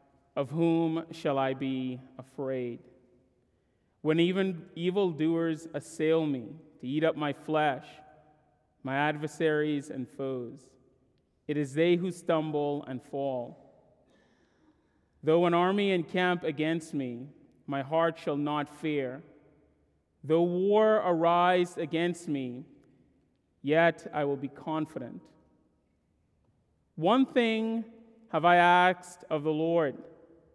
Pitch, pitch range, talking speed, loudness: 155 Hz, 135-170 Hz, 110 wpm, -29 LUFS